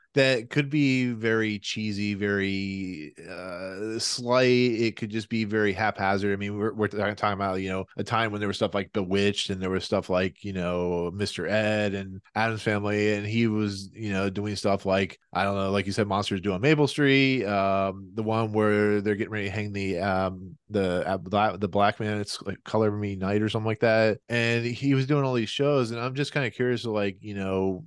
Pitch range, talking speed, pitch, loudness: 100-115 Hz, 220 wpm, 105 Hz, -26 LUFS